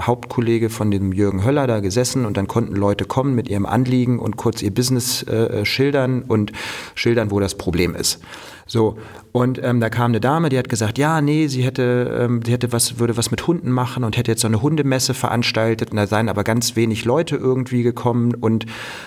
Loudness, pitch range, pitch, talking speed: -19 LUFS, 110-125 Hz, 120 Hz, 215 wpm